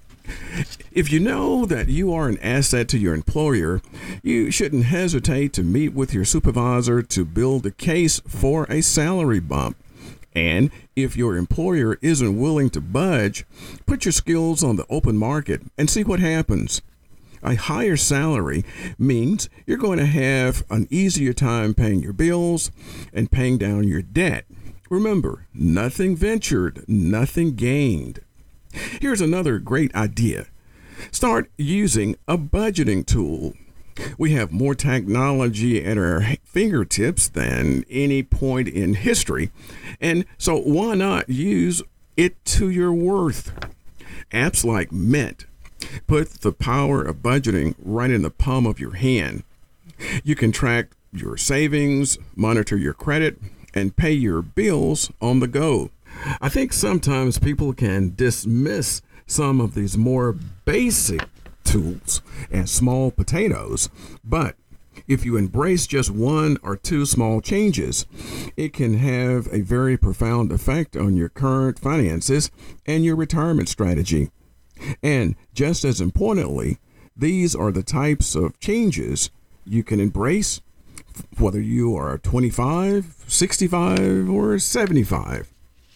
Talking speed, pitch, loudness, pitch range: 135 wpm, 125 Hz, -21 LUFS, 100-150 Hz